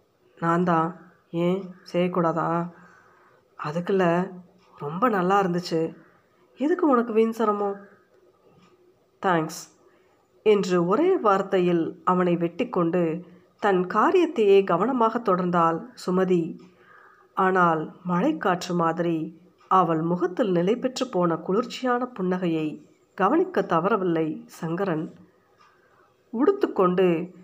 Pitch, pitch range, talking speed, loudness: 180 Hz, 170-215 Hz, 80 wpm, -24 LUFS